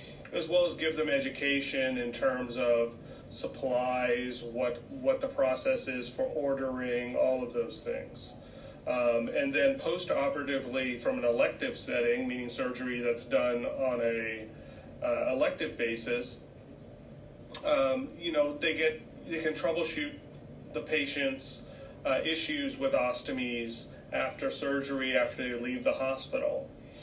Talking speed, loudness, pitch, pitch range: 130 wpm, -31 LUFS, 130 Hz, 120-160 Hz